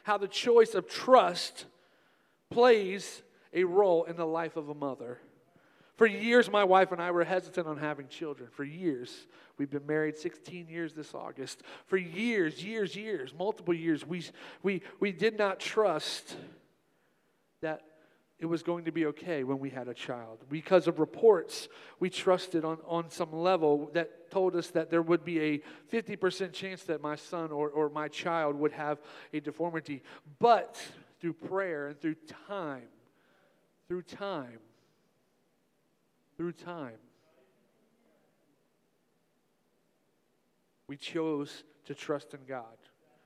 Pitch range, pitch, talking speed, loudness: 150-190 Hz, 170 Hz, 145 wpm, -31 LUFS